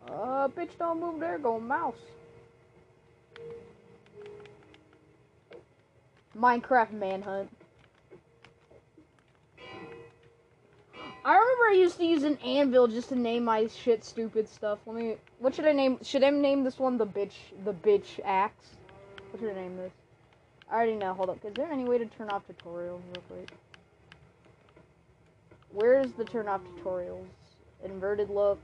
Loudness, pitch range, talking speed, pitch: -29 LUFS, 195-270 Hz, 140 wpm, 225 Hz